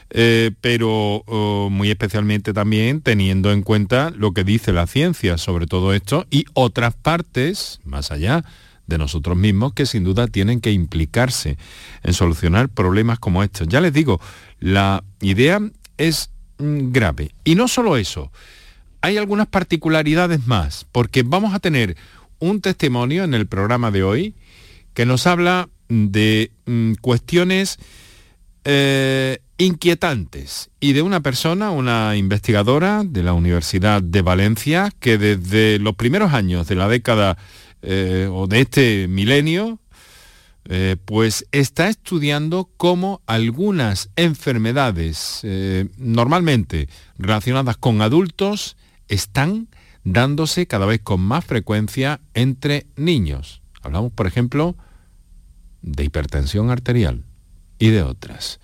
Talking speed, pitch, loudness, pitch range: 125 wpm, 110 Hz, -18 LUFS, 95-140 Hz